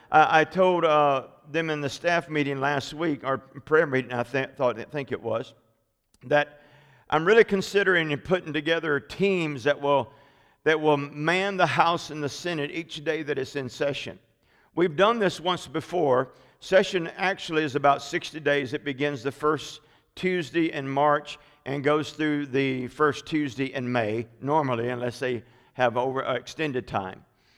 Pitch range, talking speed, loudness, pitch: 135-160 Hz, 170 wpm, -25 LUFS, 145 Hz